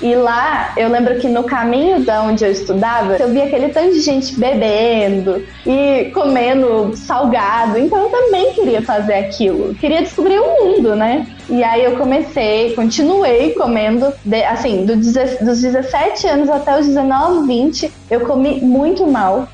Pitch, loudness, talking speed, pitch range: 255 Hz, -14 LUFS, 165 wpm, 230-290 Hz